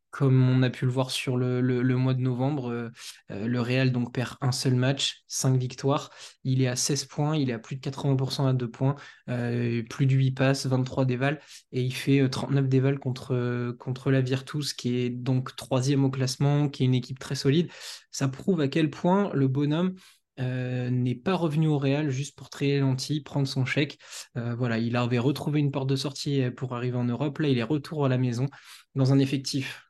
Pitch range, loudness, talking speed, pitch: 125-140 Hz, -27 LUFS, 215 wpm, 135 Hz